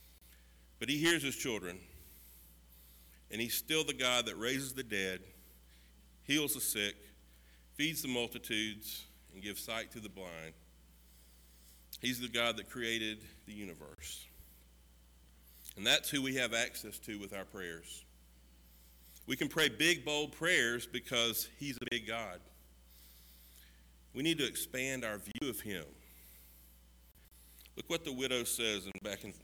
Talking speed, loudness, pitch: 145 wpm, -36 LUFS, 90 Hz